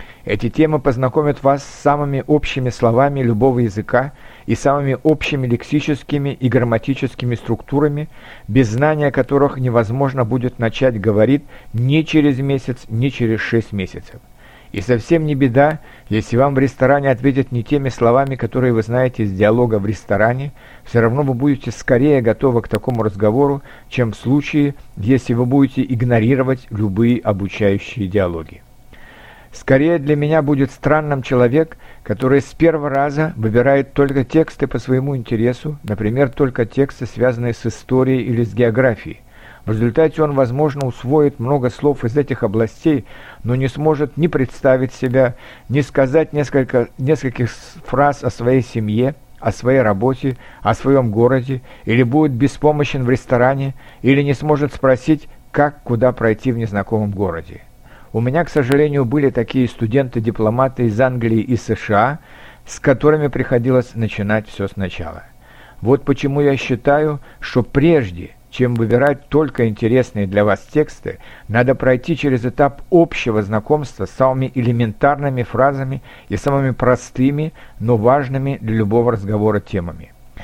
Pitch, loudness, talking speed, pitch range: 130 Hz, -17 LUFS, 140 wpm, 115-140 Hz